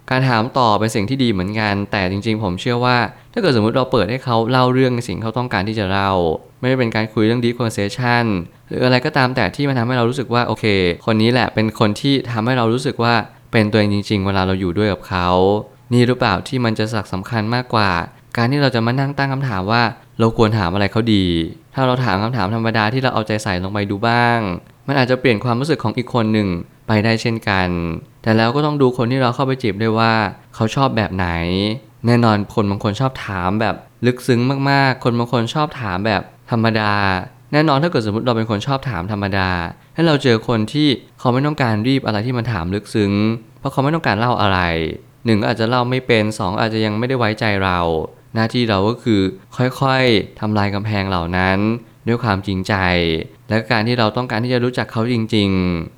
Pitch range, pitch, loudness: 105-125 Hz, 115 Hz, -17 LUFS